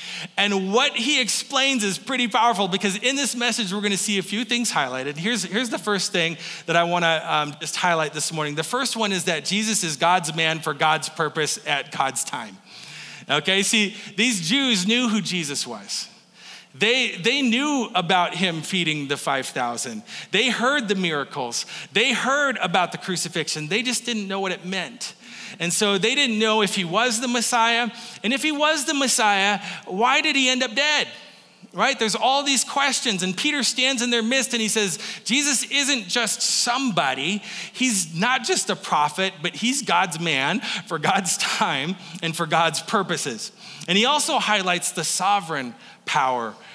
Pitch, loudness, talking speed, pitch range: 205 Hz, -21 LUFS, 185 wpm, 175-245 Hz